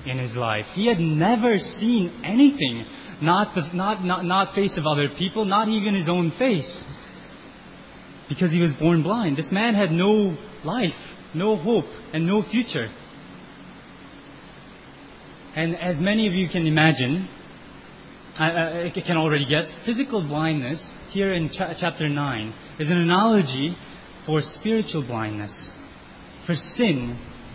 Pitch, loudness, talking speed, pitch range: 170 Hz, -23 LUFS, 140 wpm, 150-200 Hz